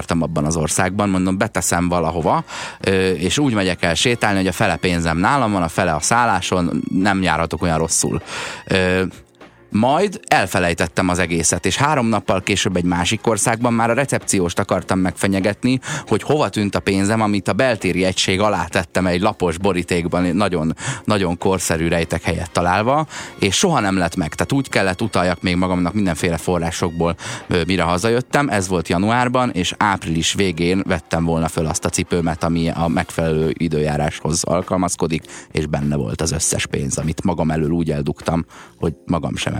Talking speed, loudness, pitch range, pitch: 165 wpm, -18 LUFS, 85-100 Hz, 95 Hz